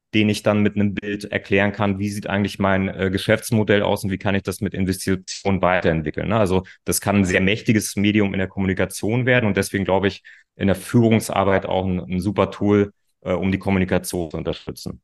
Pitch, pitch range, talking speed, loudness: 100 Hz, 95-105 Hz, 210 wpm, -20 LUFS